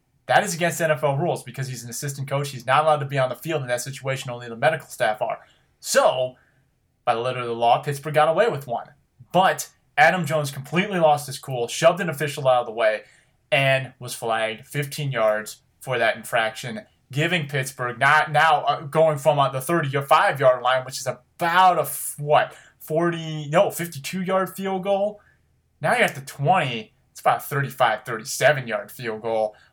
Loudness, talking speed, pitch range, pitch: -22 LUFS, 190 wpm, 125-155 Hz, 140 Hz